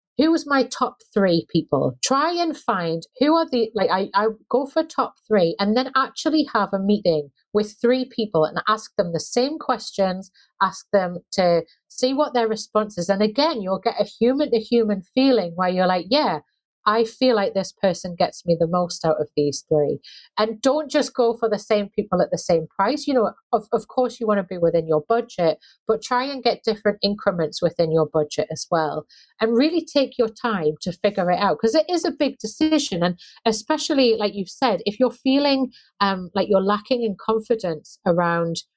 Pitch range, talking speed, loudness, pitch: 180-250 Hz, 205 wpm, -22 LUFS, 215 Hz